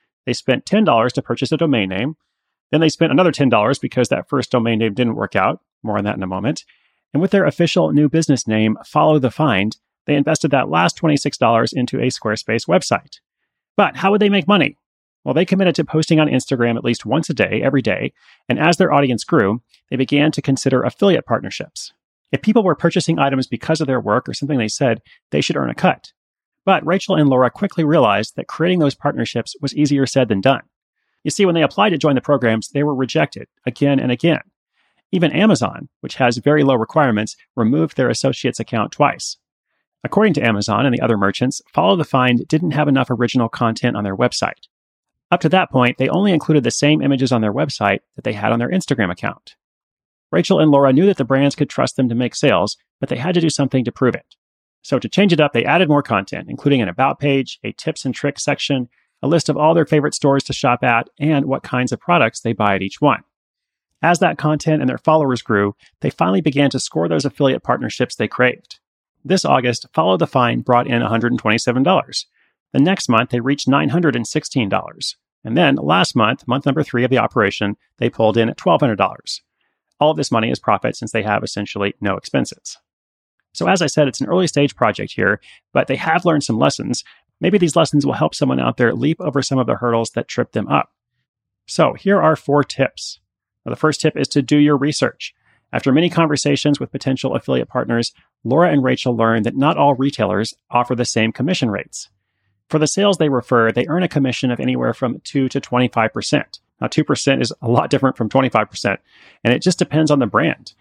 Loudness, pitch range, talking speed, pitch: -17 LUFS, 115-150 Hz, 215 wpm, 135 Hz